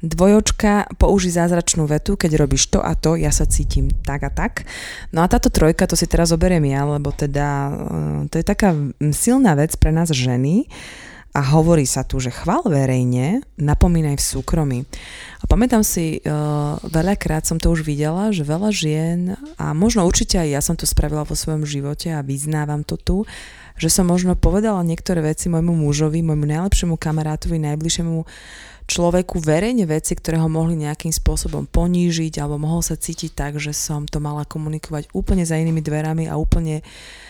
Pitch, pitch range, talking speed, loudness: 160 Hz, 150-175 Hz, 170 wpm, -19 LUFS